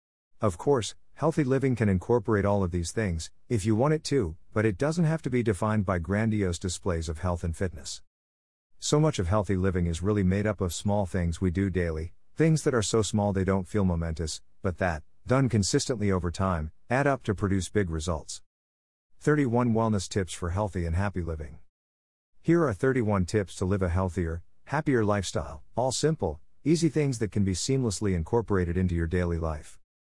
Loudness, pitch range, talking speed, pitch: -28 LUFS, 85-115 Hz, 190 wpm, 95 Hz